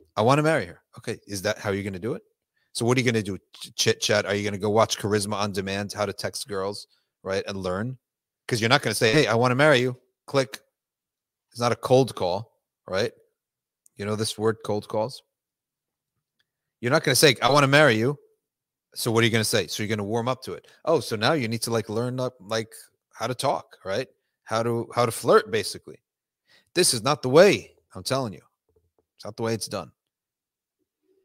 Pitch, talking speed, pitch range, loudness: 115 Hz, 235 wpm, 105-130 Hz, -24 LUFS